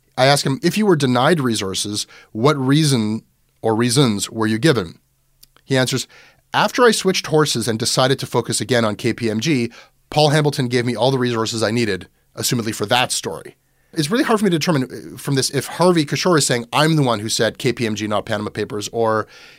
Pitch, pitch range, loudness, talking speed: 125 Hz, 110-145 Hz, -18 LUFS, 200 wpm